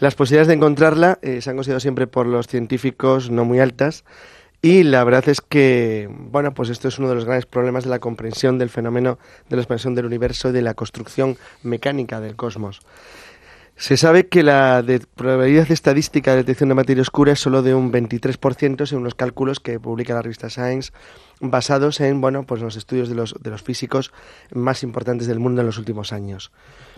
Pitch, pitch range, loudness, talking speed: 130 Hz, 120-140 Hz, -18 LUFS, 200 wpm